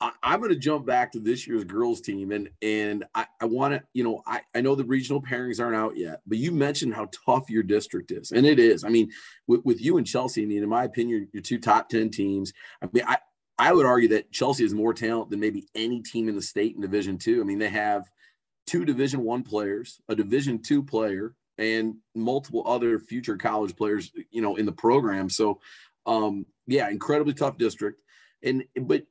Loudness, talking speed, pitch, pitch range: -26 LUFS, 220 wpm, 115 Hz, 105-130 Hz